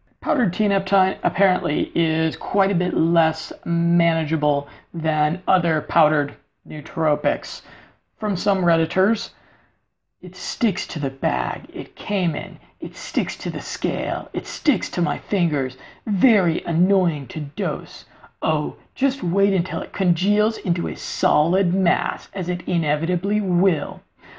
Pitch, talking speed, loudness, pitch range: 175 Hz, 130 wpm, -21 LUFS, 160-195 Hz